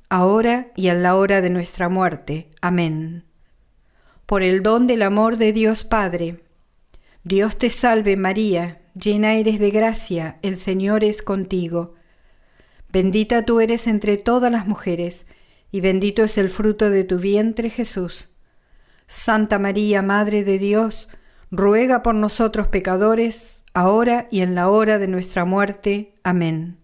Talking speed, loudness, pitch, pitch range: 140 wpm, -19 LUFS, 200 Hz, 185-220 Hz